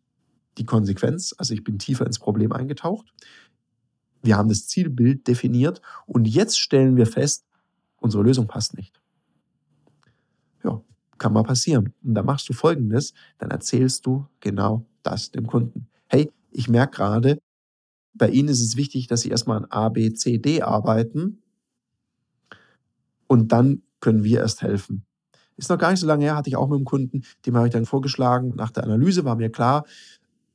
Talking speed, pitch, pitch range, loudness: 170 wpm, 125 Hz, 115-140 Hz, -22 LUFS